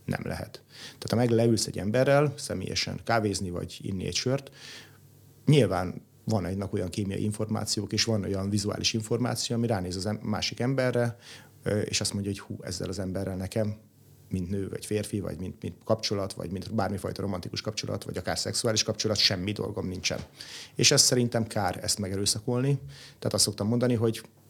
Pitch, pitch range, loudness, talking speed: 110 Hz, 100-120 Hz, -28 LUFS, 175 wpm